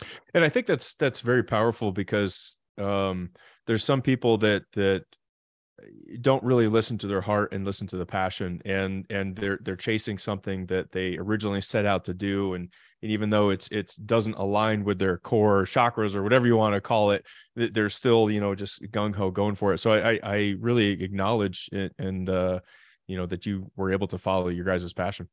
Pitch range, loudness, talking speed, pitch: 95-110 Hz, -26 LUFS, 205 wpm, 100 Hz